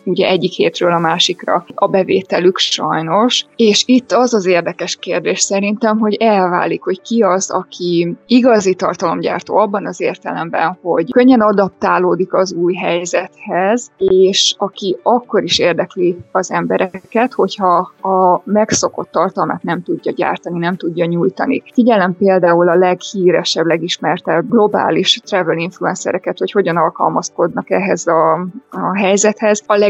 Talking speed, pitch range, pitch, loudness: 130 wpm, 175-210 Hz, 190 Hz, -14 LUFS